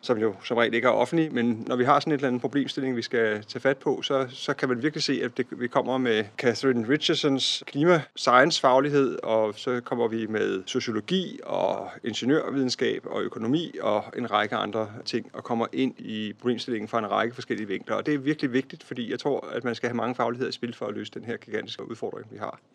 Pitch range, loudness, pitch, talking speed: 115-140 Hz, -26 LUFS, 125 Hz, 225 wpm